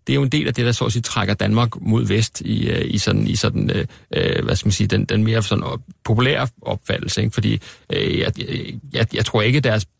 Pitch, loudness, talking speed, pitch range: 110 Hz, -20 LUFS, 250 wpm, 105-120 Hz